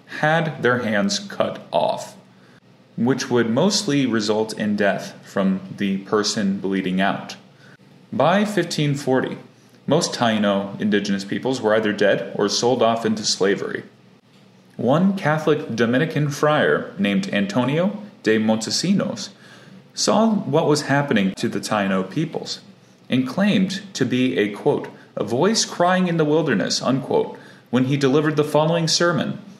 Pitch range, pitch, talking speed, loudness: 105-165 Hz, 130 Hz, 130 wpm, -20 LUFS